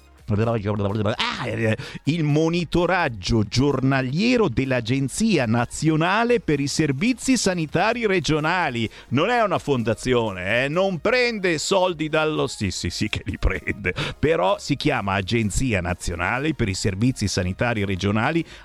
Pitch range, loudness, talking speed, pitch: 110-160 Hz, -22 LUFS, 115 wpm, 130 Hz